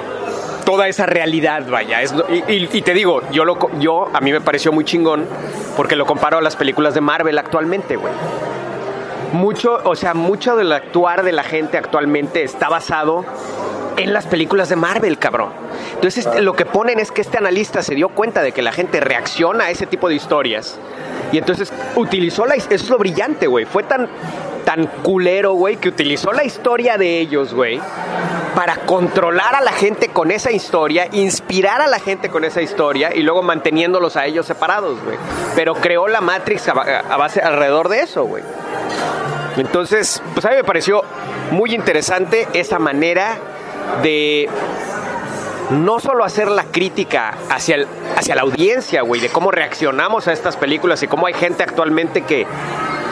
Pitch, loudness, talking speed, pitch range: 175 Hz, -16 LUFS, 175 wpm, 160-200 Hz